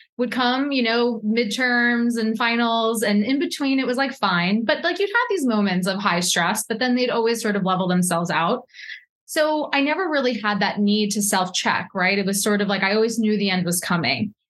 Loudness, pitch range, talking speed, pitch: -21 LUFS, 200-250 Hz, 225 wpm, 225 Hz